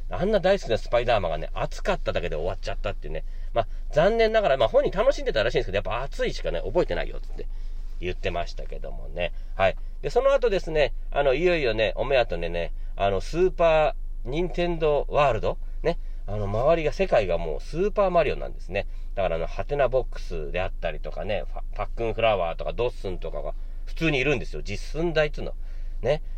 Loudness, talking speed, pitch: -26 LUFS, 455 characters per minute, 165 Hz